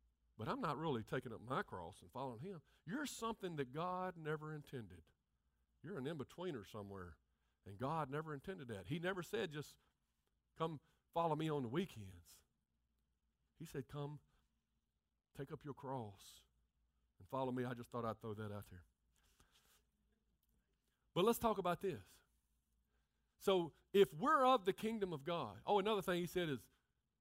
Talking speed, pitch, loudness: 160 wpm, 135 Hz, -43 LUFS